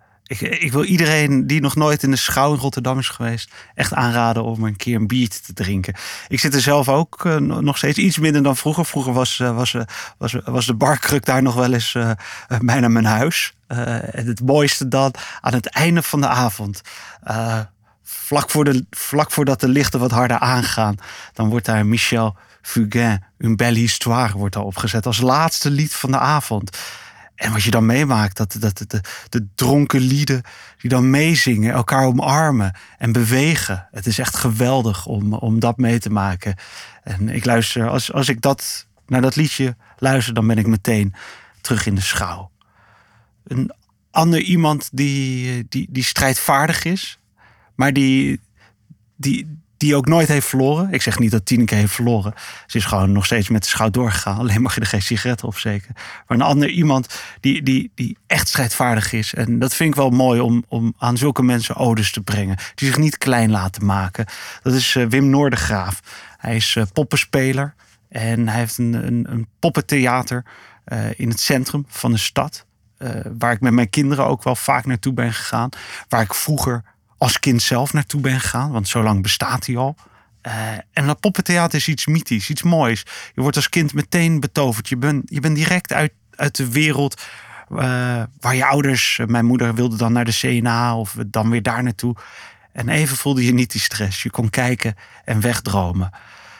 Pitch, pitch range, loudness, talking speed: 125 Hz, 110-140 Hz, -18 LUFS, 195 wpm